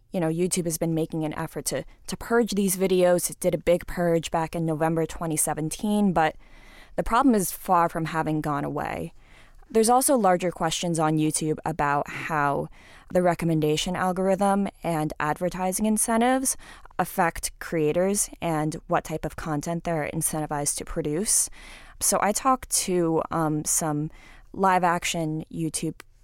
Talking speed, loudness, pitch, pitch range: 150 wpm, -25 LUFS, 165 Hz, 155-185 Hz